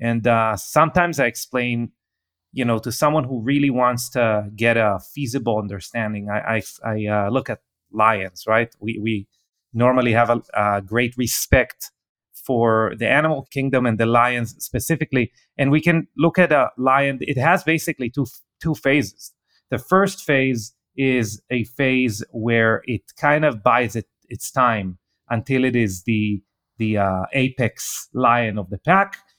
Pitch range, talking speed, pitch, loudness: 110-135 Hz, 160 wpm, 120 Hz, -20 LUFS